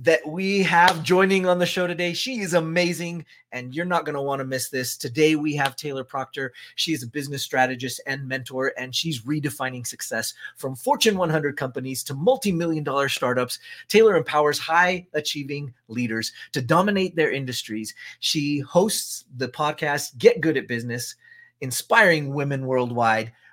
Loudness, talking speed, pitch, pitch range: -23 LUFS, 160 wpm, 145 Hz, 130-175 Hz